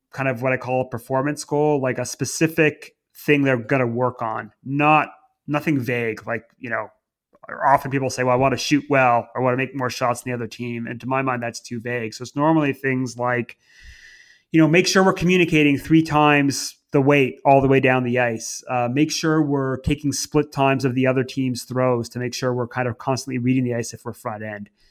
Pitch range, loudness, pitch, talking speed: 125-145 Hz, -21 LUFS, 130 Hz, 235 wpm